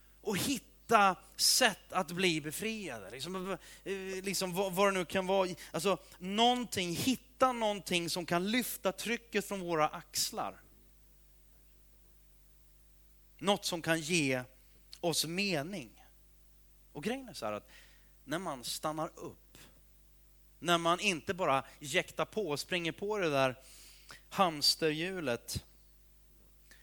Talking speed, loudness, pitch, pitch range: 120 wpm, -33 LUFS, 175 Hz, 135-195 Hz